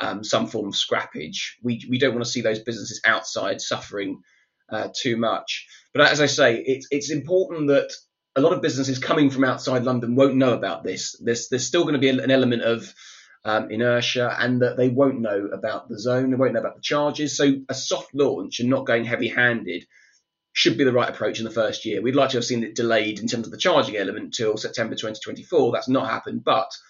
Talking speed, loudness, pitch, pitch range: 225 wpm, -22 LUFS, 125 Hz, 120-135 Hz